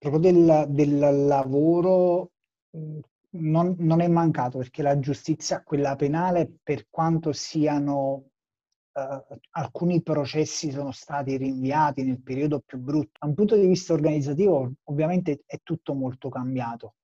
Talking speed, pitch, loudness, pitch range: 130 wpm, 150 Hz, -24 LUFS, 140-165 Hz